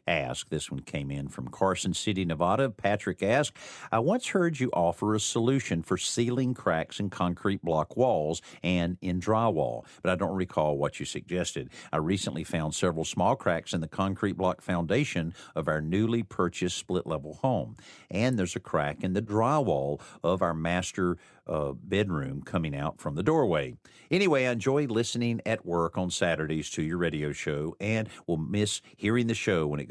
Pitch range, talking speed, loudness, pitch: 85-110 Hz, 180 wpm, -29 LUFS, 90 Hz